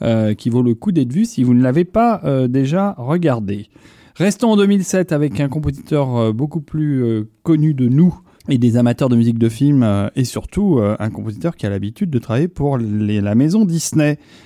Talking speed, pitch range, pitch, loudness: 210 wpm, 115-165 Hz, 135 Hz, -16 LUFS